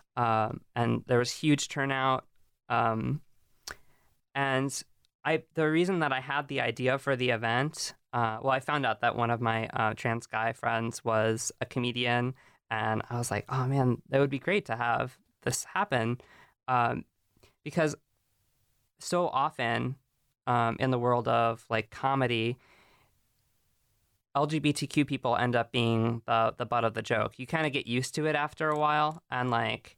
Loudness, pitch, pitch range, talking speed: -30 LUFS, 125 Hz, 115-140 Hz, 165 wpm